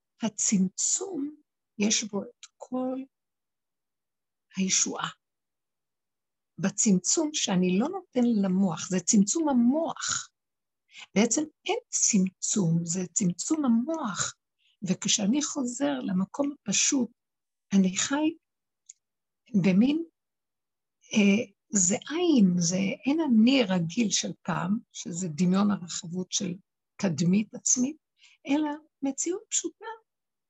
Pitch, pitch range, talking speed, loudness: 225 Hz, 190-285 Hz, 90 wpm, -26 LUFS